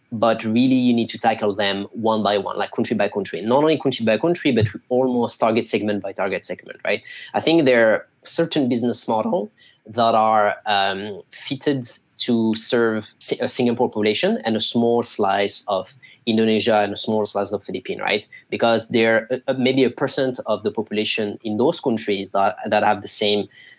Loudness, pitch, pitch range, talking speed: -20 LUFS, 110 Hz, 105-125 Hz, 185 wpm